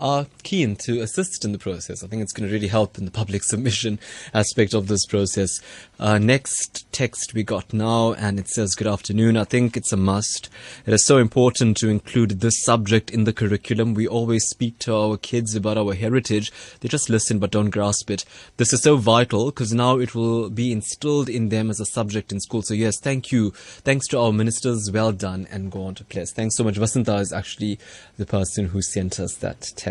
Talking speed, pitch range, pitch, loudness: 220 wpm, 105-120 Hz, 110 Hz, -21 LUFS